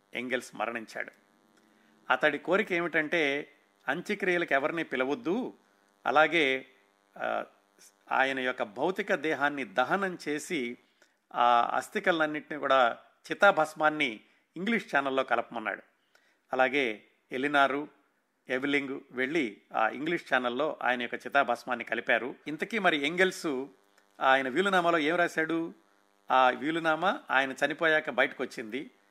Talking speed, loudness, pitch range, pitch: 95 wpm, -29 LUFS, 125-160 Hz, 140 Hz